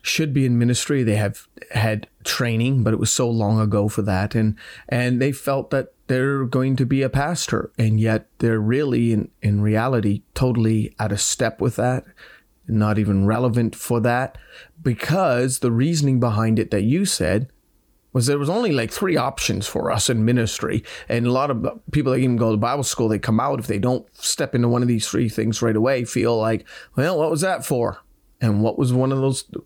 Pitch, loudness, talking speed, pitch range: 120 Hz, -21 LUFS, 210 wpm, 110-130 Hz